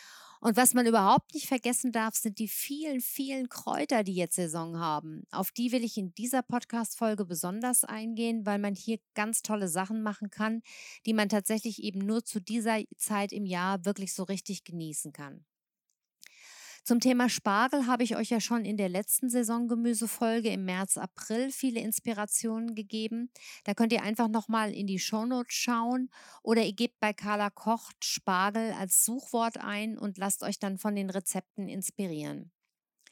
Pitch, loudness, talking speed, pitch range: 220 Hz, -30 LUFS, 170 wpm, 200-235 Hz